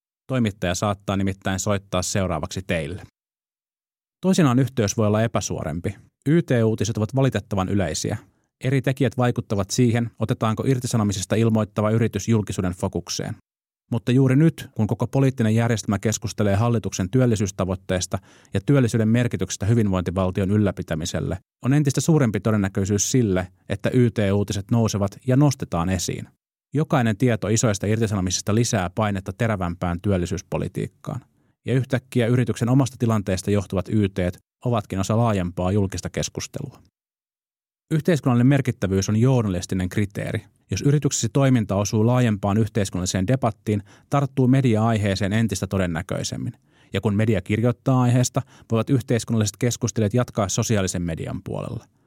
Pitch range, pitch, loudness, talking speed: 100-125 Hz, 110 Hz, -22 LUFS, 115 wpm